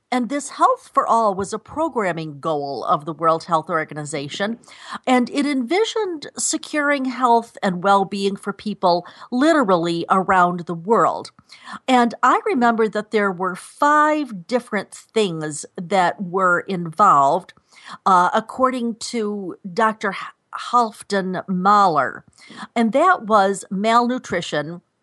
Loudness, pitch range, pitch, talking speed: -19 LUFS, 180-250 Hz, 205 Hz, 120 wpm